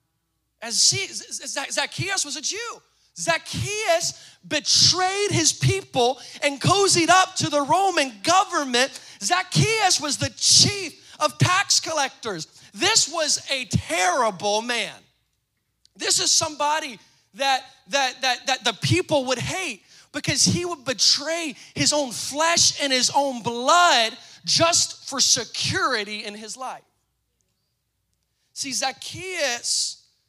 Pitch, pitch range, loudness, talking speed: 285 Hz, 240-335 Hz, -21 LUFS, 120 wpm